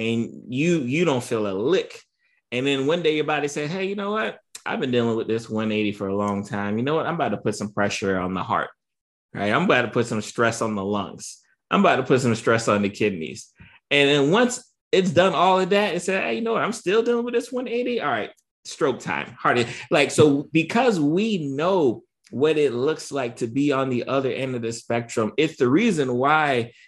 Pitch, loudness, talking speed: 145 Hz, -22 LUFS, 235 wpm